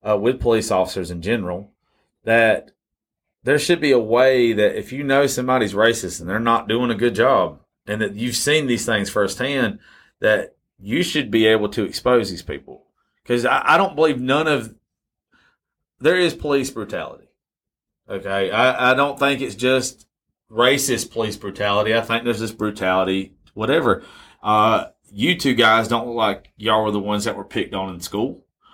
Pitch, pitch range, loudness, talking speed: 115 Hz, 105-130 Hz, -19 LUFS, 180 wpm